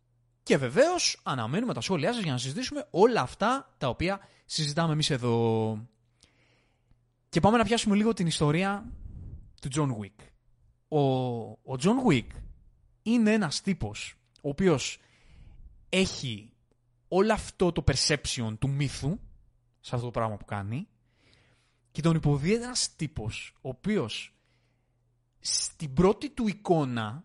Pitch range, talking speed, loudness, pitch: 120-180 Hz, 130 wpm, -28 LUFS, 130 Hz